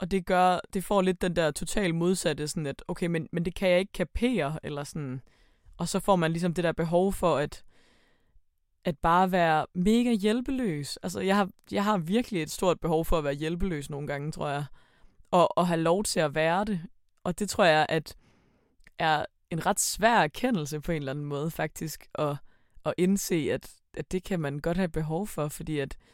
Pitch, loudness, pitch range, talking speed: 170 Hz, -28 LUFS, 150-190 Hz, 210 wpm